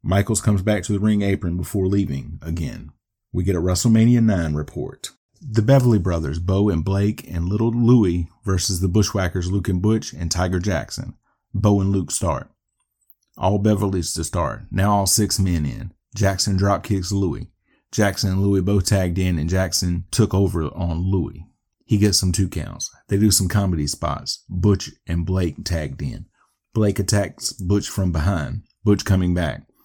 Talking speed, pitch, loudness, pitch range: 175 wpm, 95 Hz, -21 LUFS, 90-105 Hz